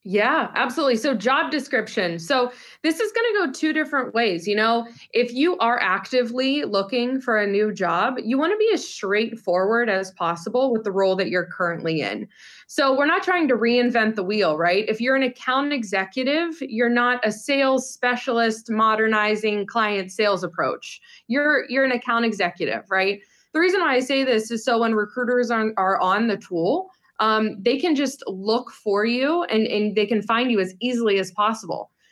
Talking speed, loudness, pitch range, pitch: 185 wpm, -22 LUFS, 205-265 Hz, 230 Hz